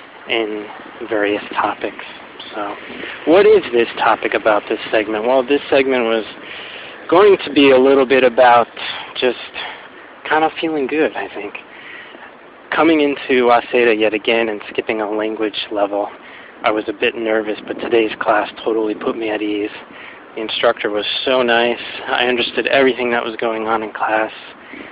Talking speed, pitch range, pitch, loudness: 160 wpm, 110-130 Hz, 115 Hz, -16 LUFS